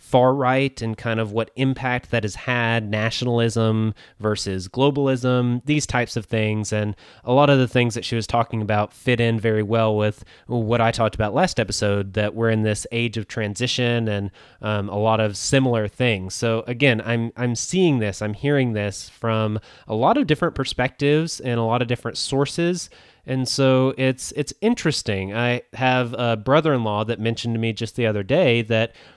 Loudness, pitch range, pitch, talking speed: -21 LUFS, 110-130 Hz, 115 Hz, 190 wpm